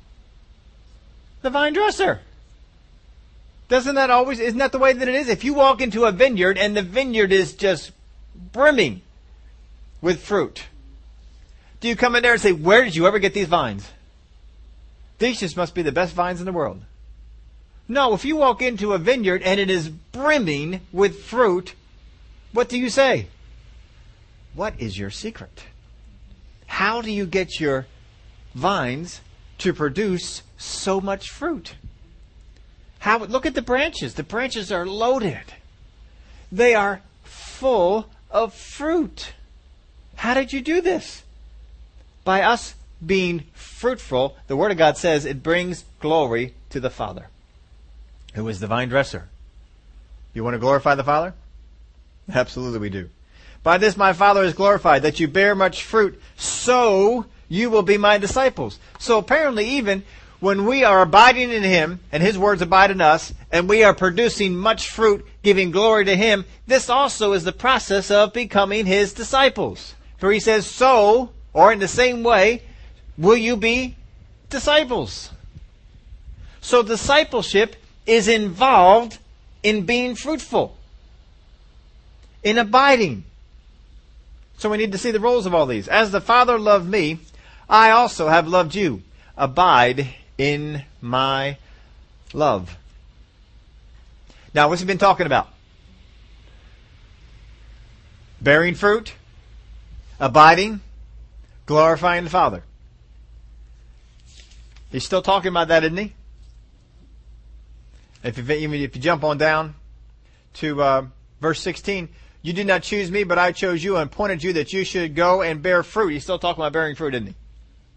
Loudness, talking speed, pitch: -19 LUFS, 145 wpm, 180 Hz